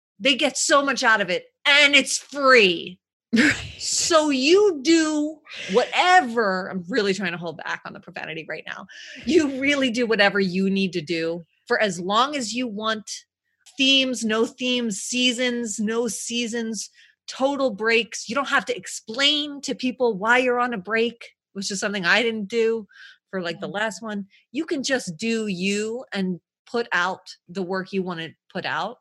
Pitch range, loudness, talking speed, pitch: 200-270 Hz, -21 LUFS, 175 wpm, 235 Hz